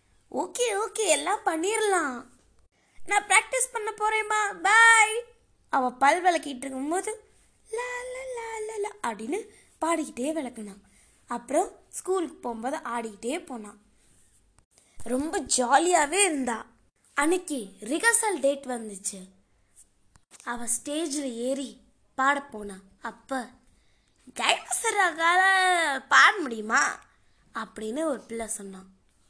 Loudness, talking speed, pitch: -25 LUFS, 80 wpm, 295 Hz